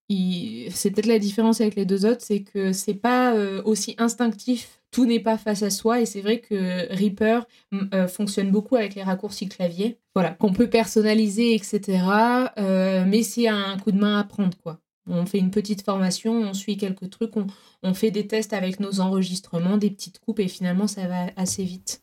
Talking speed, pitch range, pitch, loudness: 190 wpm, 190-225 Hz, 205 Hz, -23 LUFS